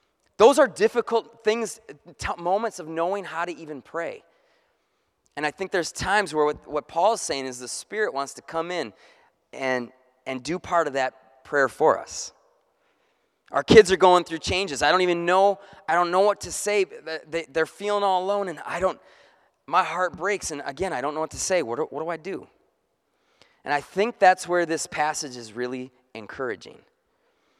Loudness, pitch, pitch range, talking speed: -24 LUFS, 175 Hz, 145-200 Hz, 195 wpm